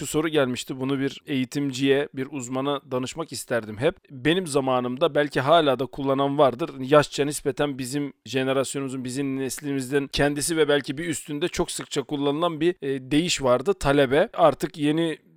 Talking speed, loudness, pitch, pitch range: 150 wpm, -24 LUFS, 140 Hz, 135-150 Hz